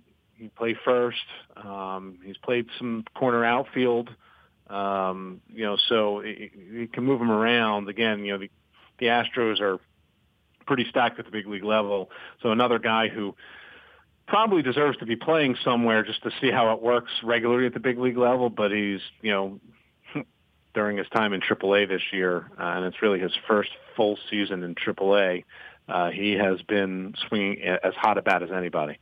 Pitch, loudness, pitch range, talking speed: 110 Hz, -25 LUFS, 100-120 Hz, 180 wpm